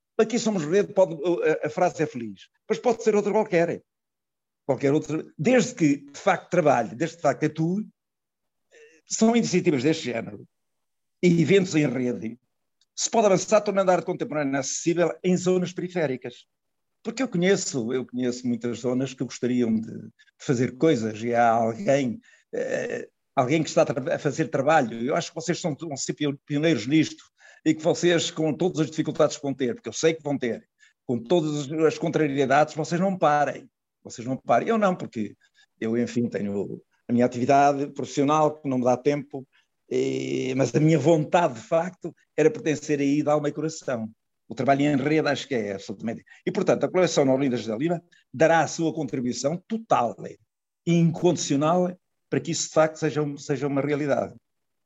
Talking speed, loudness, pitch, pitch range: 180 wpm, -24 LUFS, 155 Hz, 135-175 Hz